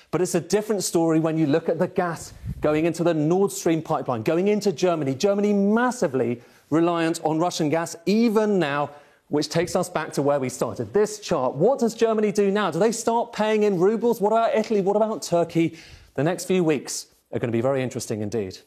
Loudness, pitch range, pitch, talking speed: -23 LUFS, 155-205 Hz, 175 Hz, 210 wpm